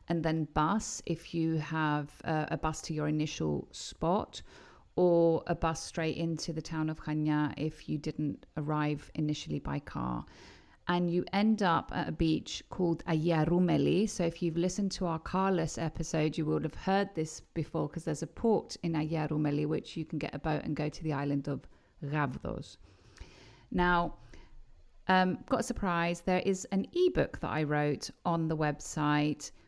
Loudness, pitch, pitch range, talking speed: -32 LUFS, 160 Hz, 150-175 Hz, 175 wpm